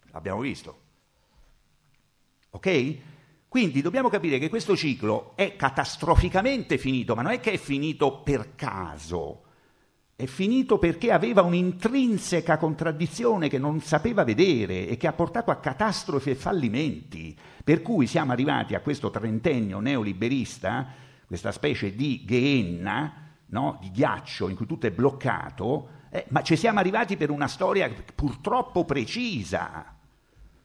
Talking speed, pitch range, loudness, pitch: 135 wpm, 130-190 Hz, -26 LUFS, 150 Hz